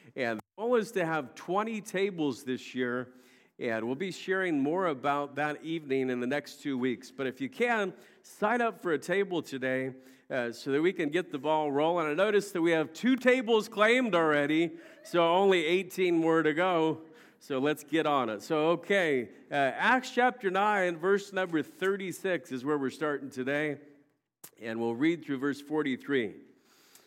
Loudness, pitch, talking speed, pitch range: -30 LUFS, 160 Hz, 180 wpm, 140-190 Hz